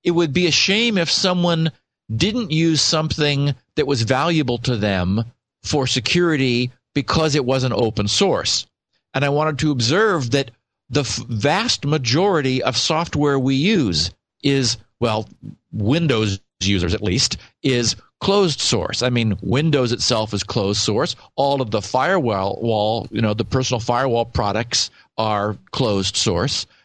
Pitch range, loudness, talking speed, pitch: 110-150 Hz, -19 LUFS, 150 wpm, 130 Hz